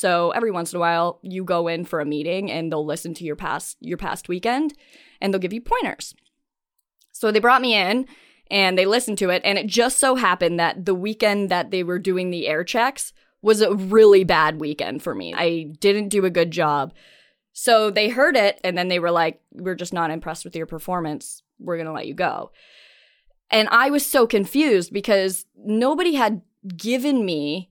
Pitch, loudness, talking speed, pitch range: 190 Hz, -20 LUFS, 210 wpm, 170-230 Hz